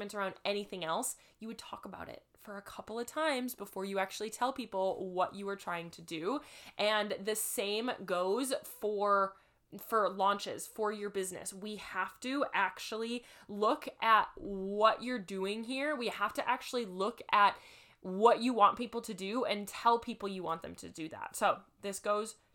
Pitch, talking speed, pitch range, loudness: 210 Hz, 180 wpm, 195-235 Hz, -34 LUFS